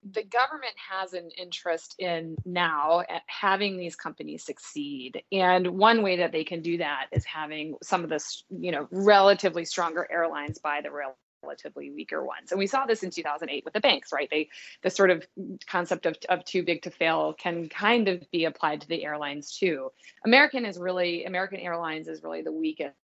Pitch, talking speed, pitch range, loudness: 180 Hz, 200 wpm, 160-195 Hz, -27 LUFS